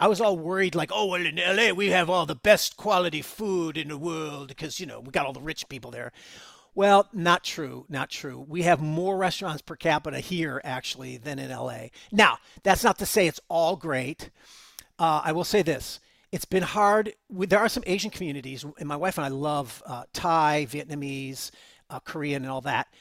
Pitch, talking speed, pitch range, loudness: 165 Hz, 210 wpm, 140-185 Hz, -26 LUFS